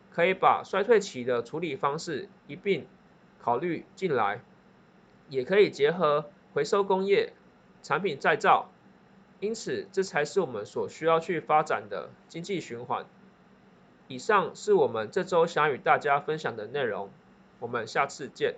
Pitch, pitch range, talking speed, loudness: 195 Hz, 155-225 Hz, 225 characters per minute, -28 LUFS